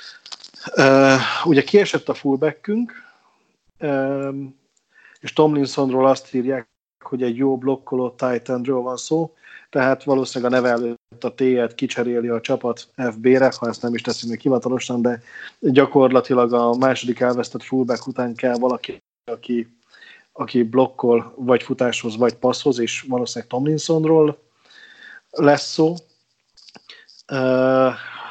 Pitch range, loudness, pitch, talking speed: 120-135 Hz, -19 LUFS, 130 Hz, 120 wpm